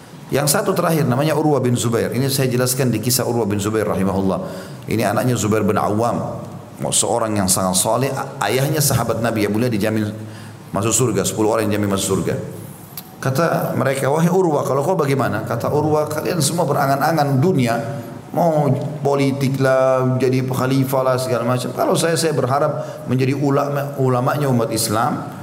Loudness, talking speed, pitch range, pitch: -18 LUFS, 160 wpm, 115-145 Hz, 130 Hz